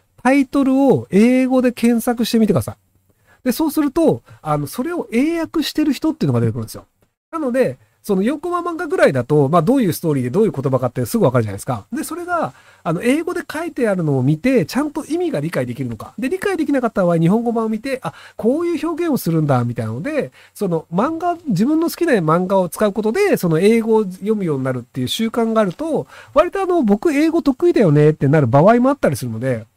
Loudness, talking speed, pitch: -17 LUFS, 465 characters per minute, 220 Hz